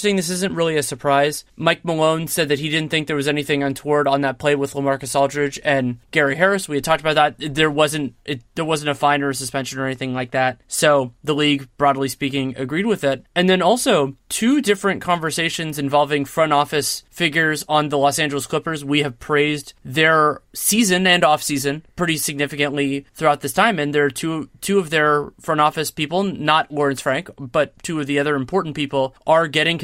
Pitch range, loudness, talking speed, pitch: 140-160 Hz, -19 LUFS, 205 wpm, 150 Hz